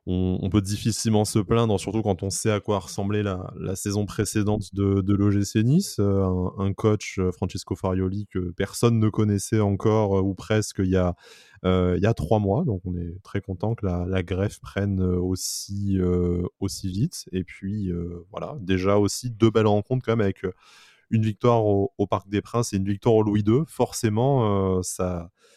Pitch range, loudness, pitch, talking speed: 95-110 Hz, -24 LUFS, 100 Hz, 200 wpm